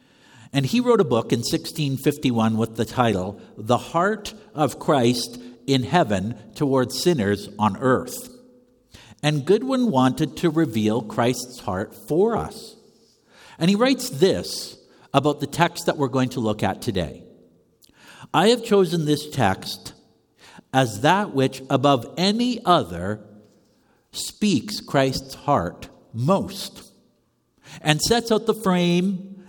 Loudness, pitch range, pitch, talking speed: -22 LUFS, 120-190 Hz, 145 Hz, 130 wpm